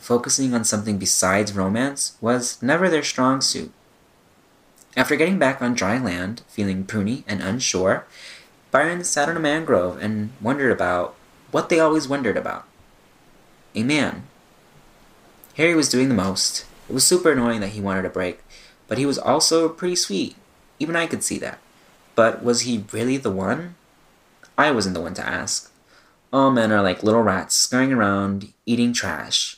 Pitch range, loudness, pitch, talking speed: 100-140 Hz, -21 LUFS, 120 Hz, 165 wpm